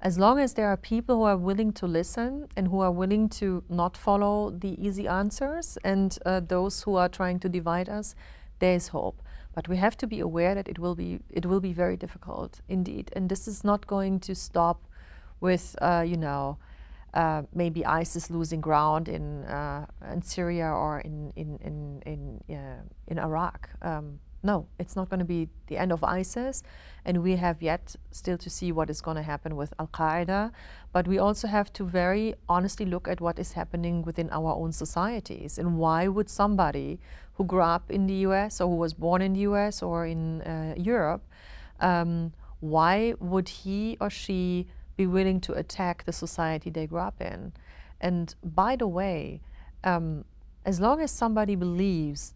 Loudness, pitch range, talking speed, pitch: -28 LUFS, 165-195 Hz, 190 wpm, 180 Hz